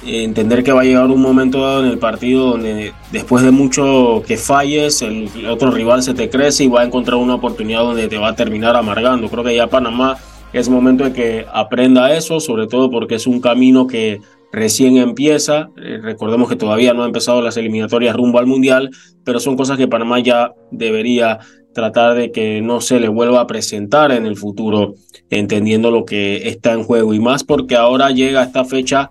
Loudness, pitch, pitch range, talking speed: -13 LUFS, 120 Hz, 115-130 Hz, 200 wpm